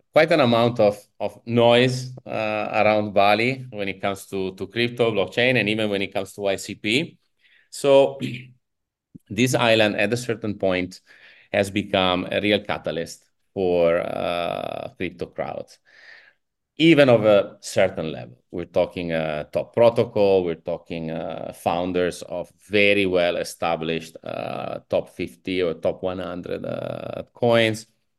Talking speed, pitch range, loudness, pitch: 140 wpm, 90-115 Hz, -22 LUFS, 105 Hz